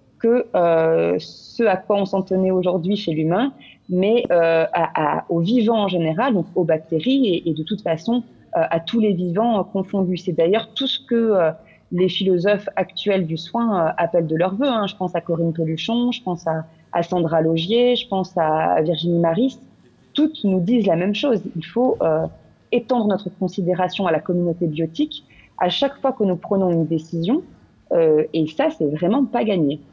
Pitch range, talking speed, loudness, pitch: 165-225 Hz, 195 wpm, -20 LUFS, 185 Hz